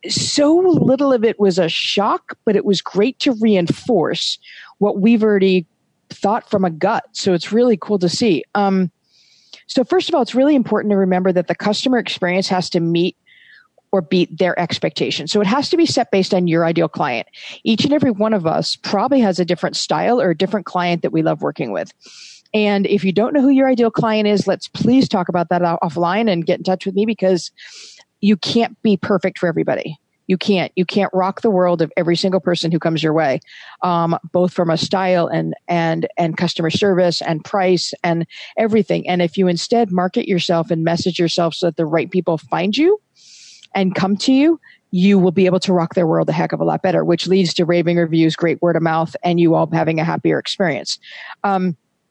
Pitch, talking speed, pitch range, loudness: 185 Hz, 215 wpm, 175-215 Hz, -17 LUFS